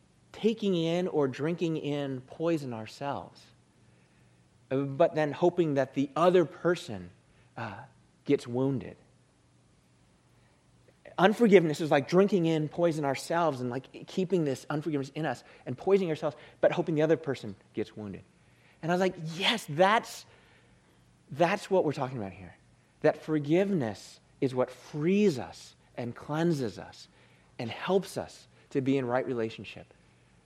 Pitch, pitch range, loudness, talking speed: 150 Hz, 125-175 Hz, -29 LUFS, 140 wpm